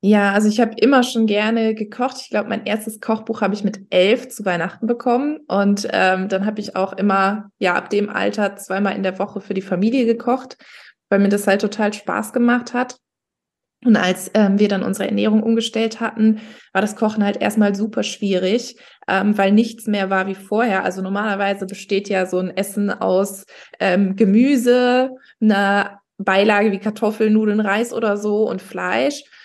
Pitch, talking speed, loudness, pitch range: 210 Hz, 180 wpm, -19 LUFS, 195-230 Hz